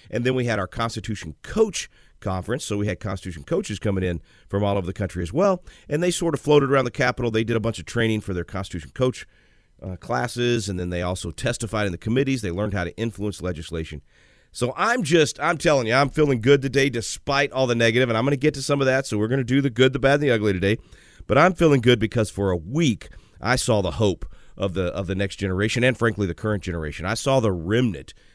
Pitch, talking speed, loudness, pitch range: 110 Hz, 250 wpm, -23 LUFS, 95-130 Hz